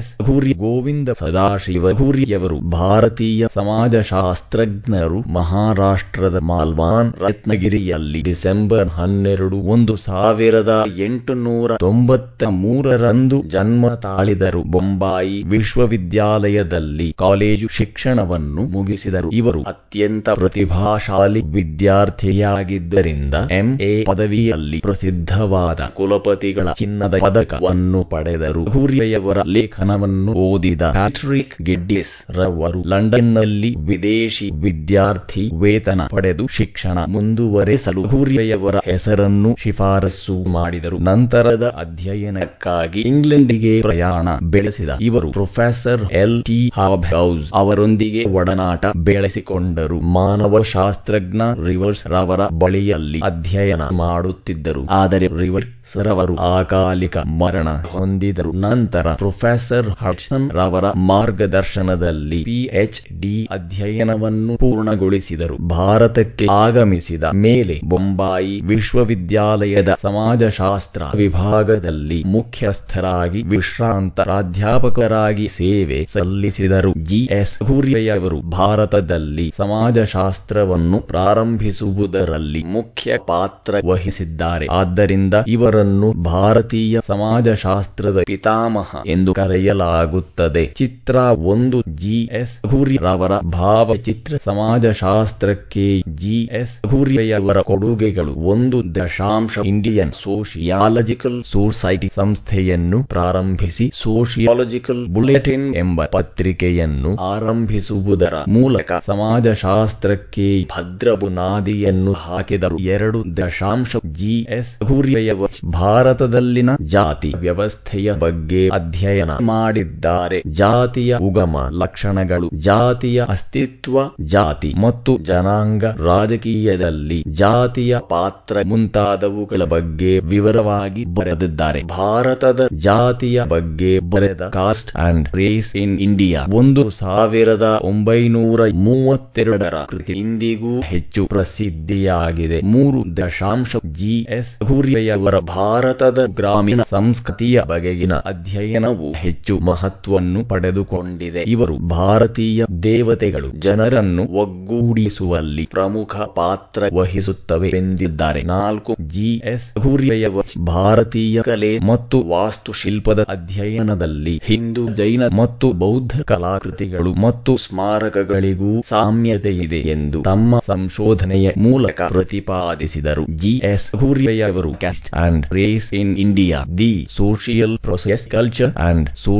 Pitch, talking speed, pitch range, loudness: 100 Hz, 80 wpm, 90-115 Hz, -16 LUFS